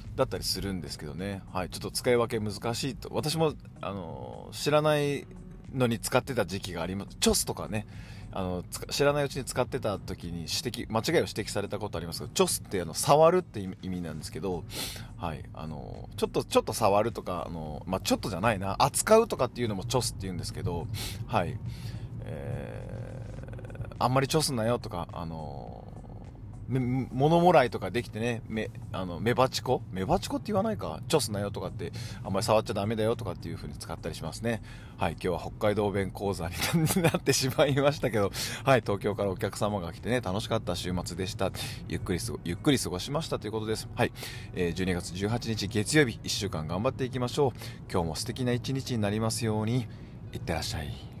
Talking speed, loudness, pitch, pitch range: 415 characters per minute, -30 LUFS, 110 Hz, 100-125 Hz